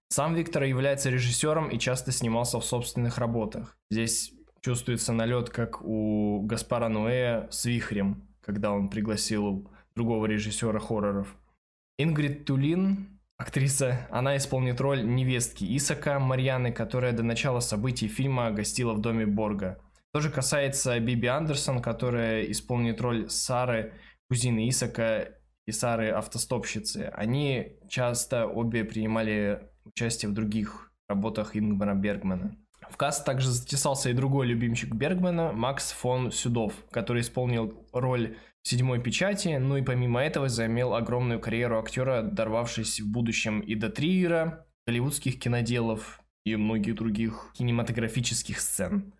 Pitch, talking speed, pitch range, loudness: 120 Hz, 125 wpm, 110-130 Hz, -28 LUFS